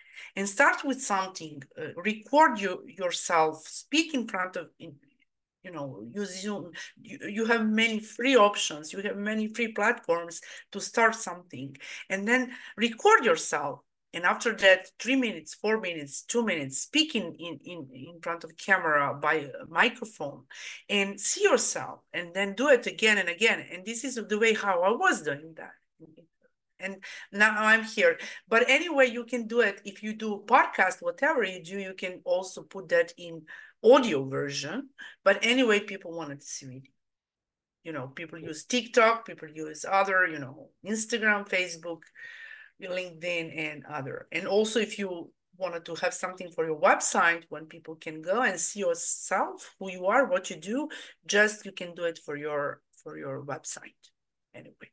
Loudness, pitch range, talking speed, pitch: -27 LUFS, 170-235 Hz, 170 wpm, 195 Hz